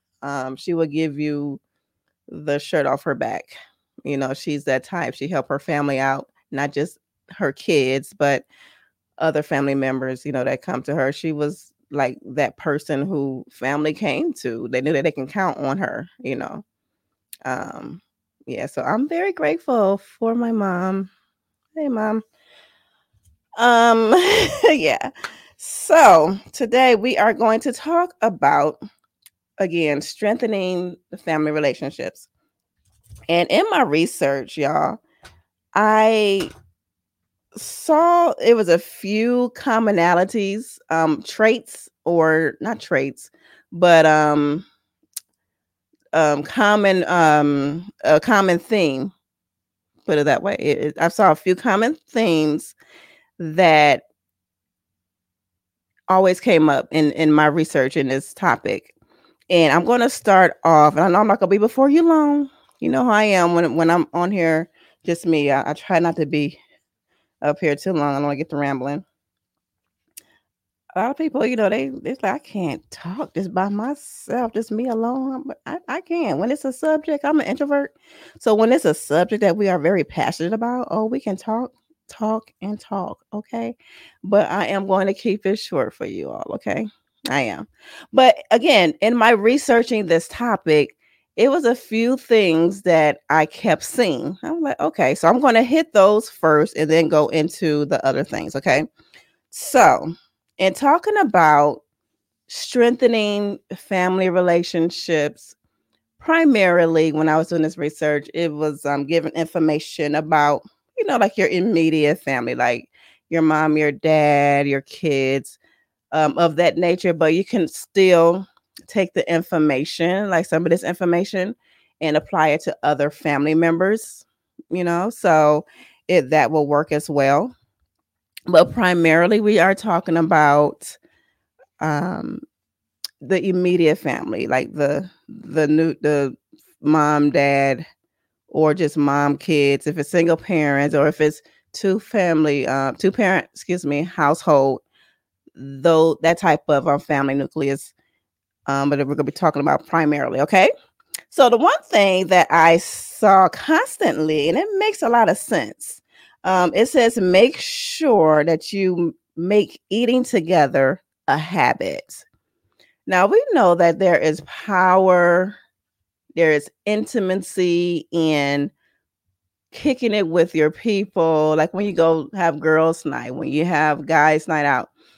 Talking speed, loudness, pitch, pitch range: 150 wpm, -18 LUFS, 170 Hz, 150-215 Hz